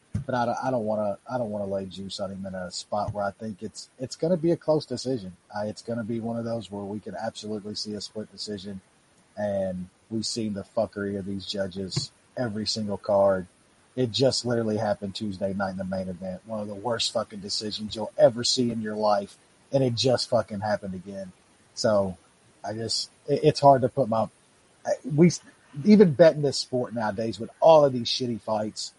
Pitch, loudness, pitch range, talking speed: 105 Hz, -26 LUFS, 100-125 Hz, 215 wpm